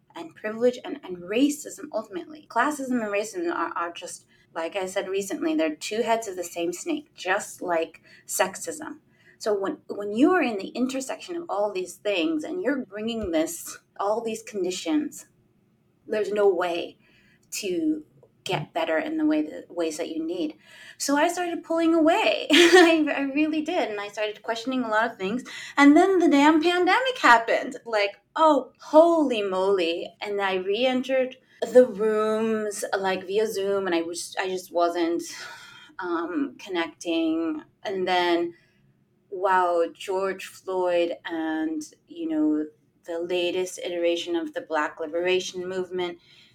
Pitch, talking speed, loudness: 220 Hz, 150 wpm, -25 LUFS